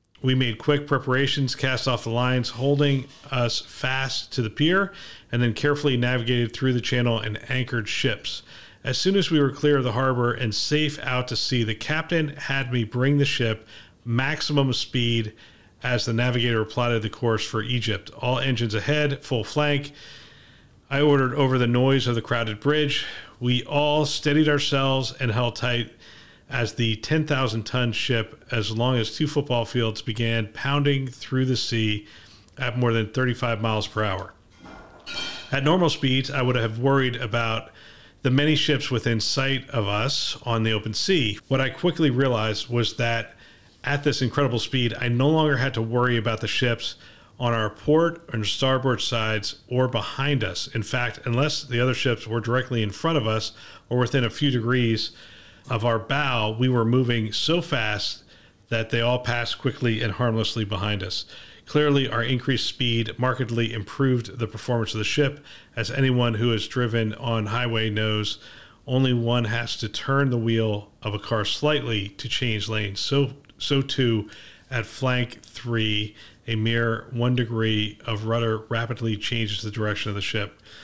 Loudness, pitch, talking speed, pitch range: -24 LUFS, 120 Hz, 170 wpm, 110-135 Hz